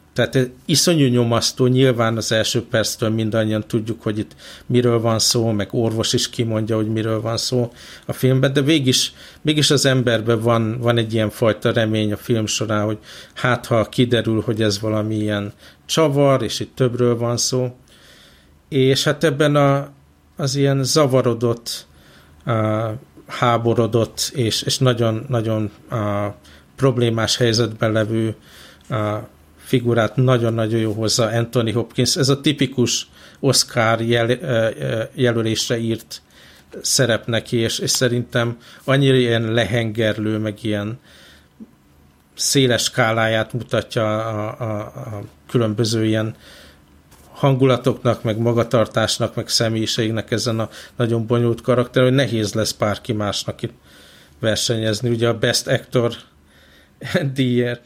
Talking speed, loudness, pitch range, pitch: 125 wpm, -19 LUFS, 110-125 Hz, 115 Hz